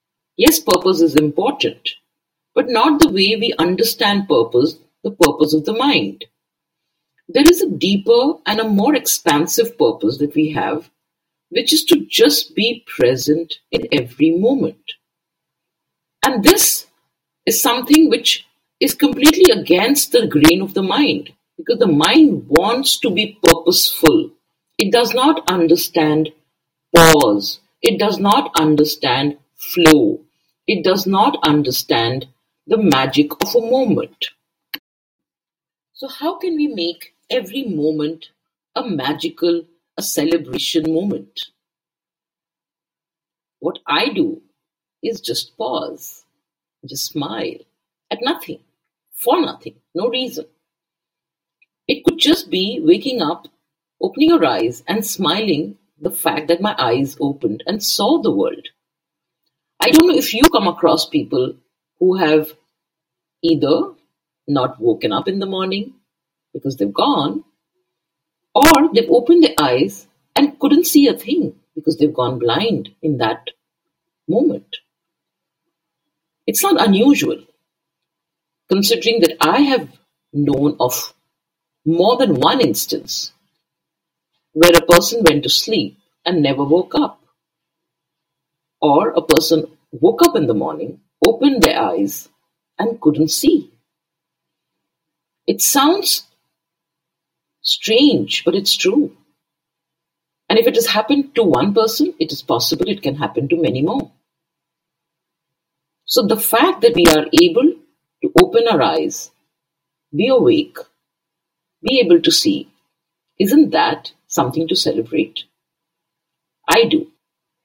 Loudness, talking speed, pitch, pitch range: -15 LUFS, 125 wpm, 165 Hz, 165-250 Hz